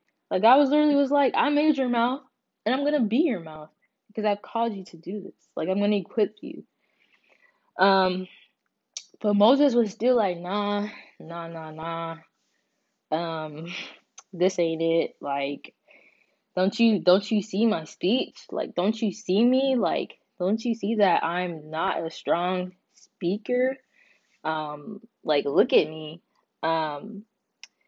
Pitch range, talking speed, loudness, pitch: 170-240 Hz, 155 wpm, -25 LUFS, 205 Hz